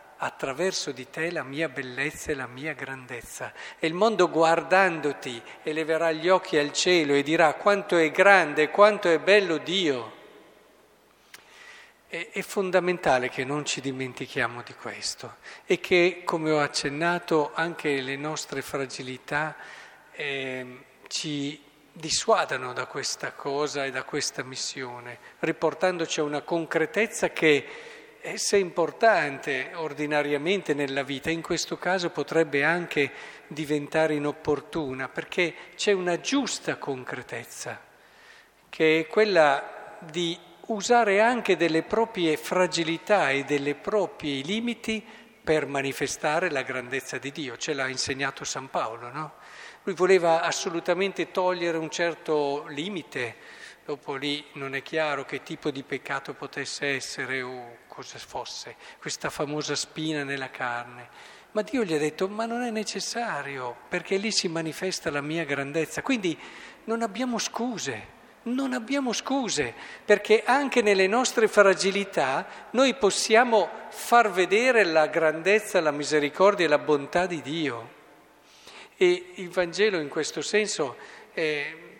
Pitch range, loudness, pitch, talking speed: 145-200 Hz, -26 LUFS, 160 Hz, 130 wpm